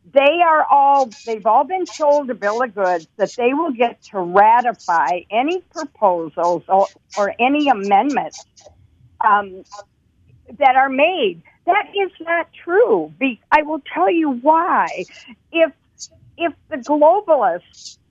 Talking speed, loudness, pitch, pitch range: 135 wpm, -17 LUFS, 275 Hz, 205-325 Hz